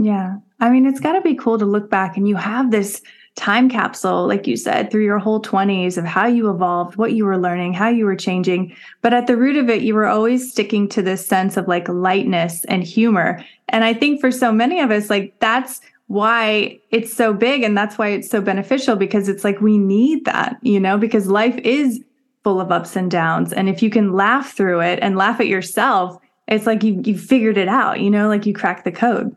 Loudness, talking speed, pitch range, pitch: -17 LUFS, 235 wpm, 195-235 Hz, 215 Hz